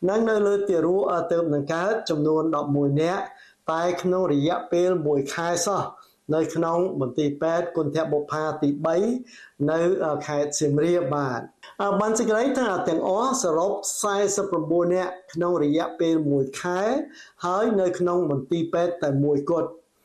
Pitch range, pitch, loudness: 150-185 Hz, 170 Hz, -24 LUFS